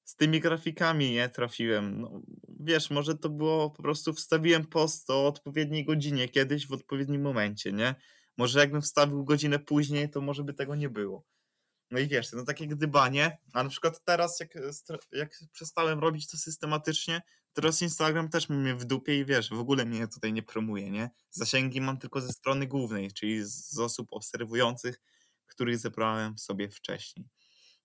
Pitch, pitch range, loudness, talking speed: 140 Hz, 125-155 Hz, -30 LUFS, 170 wpm